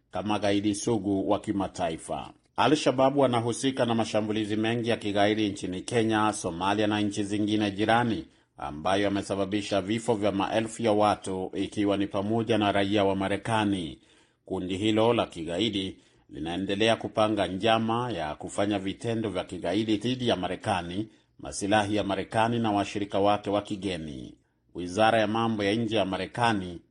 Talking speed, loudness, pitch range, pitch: 135 wpm, -27 LUFS, 100-110 Hz, 105 Hz